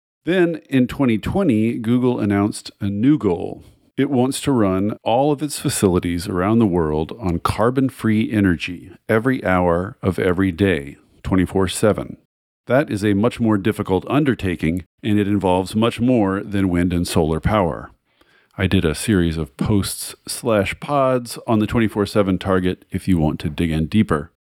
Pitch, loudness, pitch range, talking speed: 100 Hz, -19 LUFS, 90-115 Hz, 165 wpm